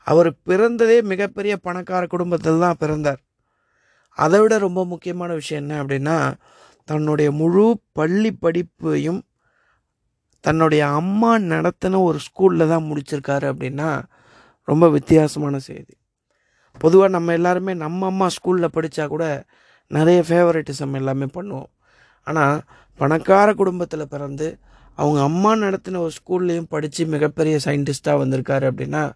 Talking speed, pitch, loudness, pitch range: 115 wpm, 160 Hz, -19 LUFS, 145-180 Hz